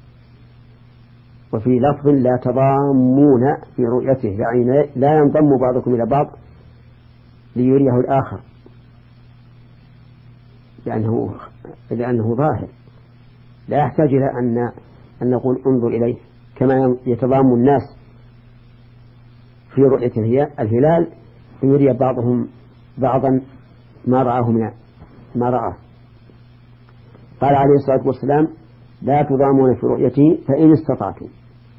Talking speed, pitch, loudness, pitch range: 95 wpm, 125 Hz, -17 LUFS, 120-135 Hz